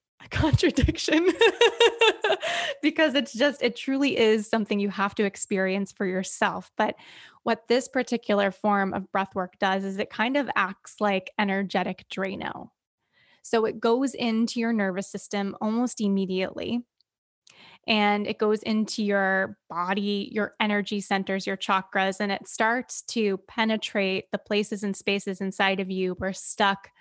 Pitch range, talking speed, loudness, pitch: 195-230 Hz, 145 wpm, -25 LUFS, 205 Hz